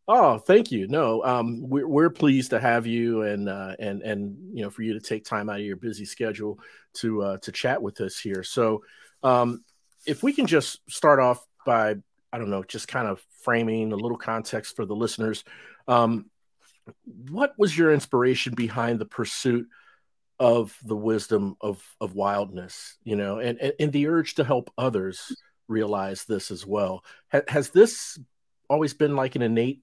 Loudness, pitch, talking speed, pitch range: -25 LUFS, 115 Hz, 185 wpm, 105-125 Hz